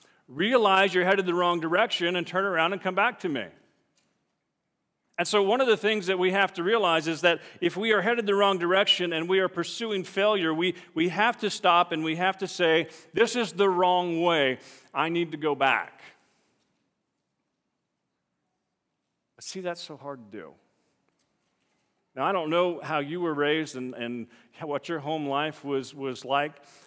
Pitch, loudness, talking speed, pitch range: 175 Hz, -25 LUFS, 185 wpm, 150-190 Hz